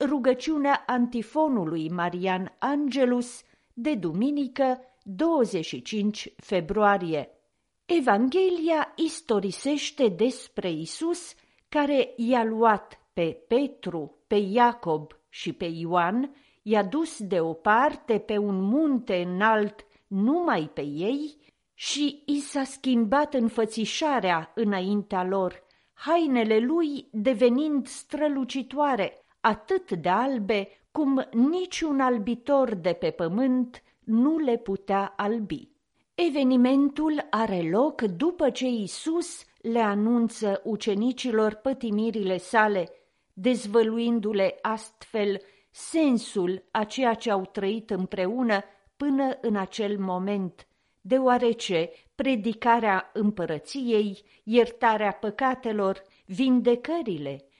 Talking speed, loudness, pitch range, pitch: 90 wpm, -26 LUFS, 200-270 Hz, 230 Hz